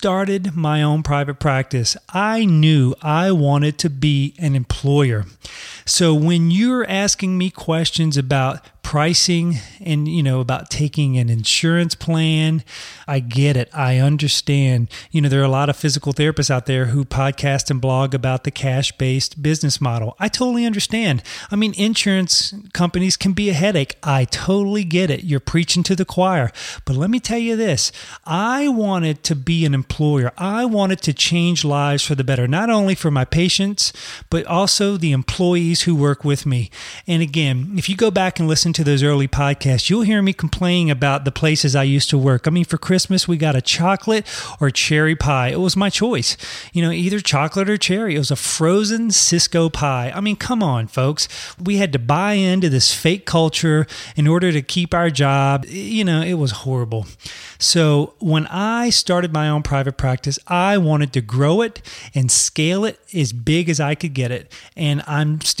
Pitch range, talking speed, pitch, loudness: 140-185 Hz, 190 wpm, 155 Hz, -17 LUFS